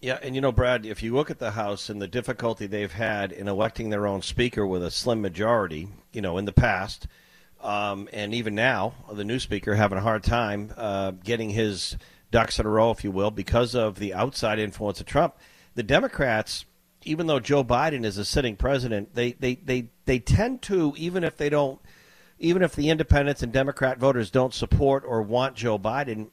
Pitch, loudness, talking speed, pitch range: 115 Hz, -25 LUFS, 205 wpm, 105-130 Hz